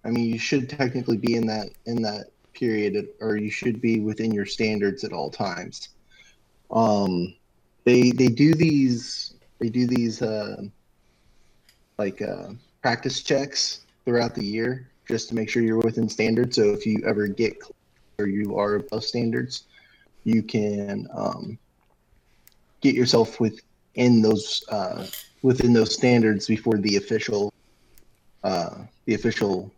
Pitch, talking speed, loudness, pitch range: 115 Hz, 145 wpm, -24 LUFS, 105-125 Hz